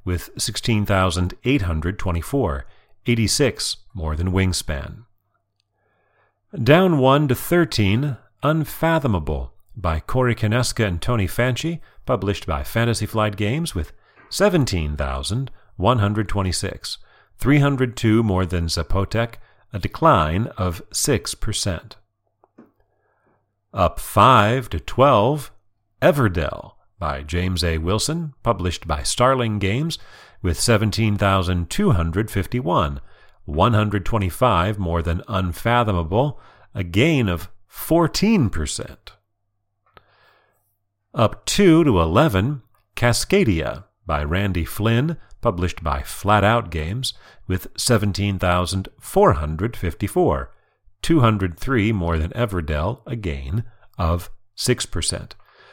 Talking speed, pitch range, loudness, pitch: 85 wpm, 90-120 Hz, -20 LUFS, 105 Hz